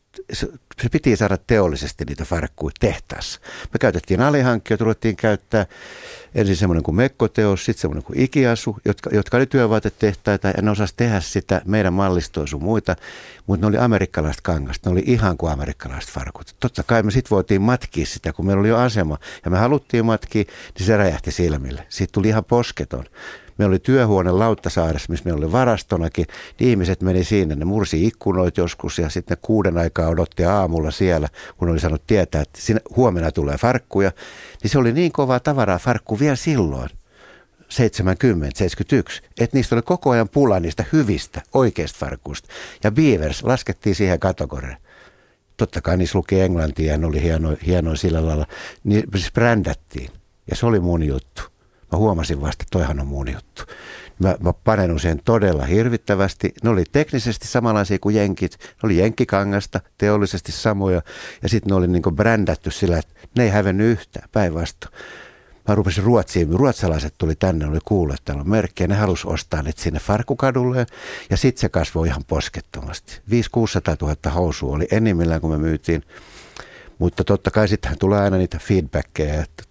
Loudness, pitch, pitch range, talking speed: -20 LUFS, 95 Hz, 80-110 Hz, 165 wpm